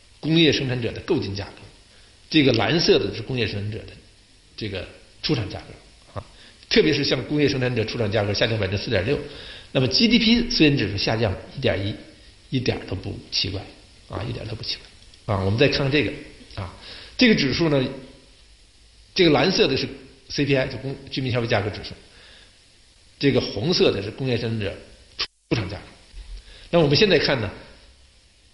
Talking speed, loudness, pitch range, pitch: 280 characters per minute, -22 LUFS, 100-135 Hz, 115 Hz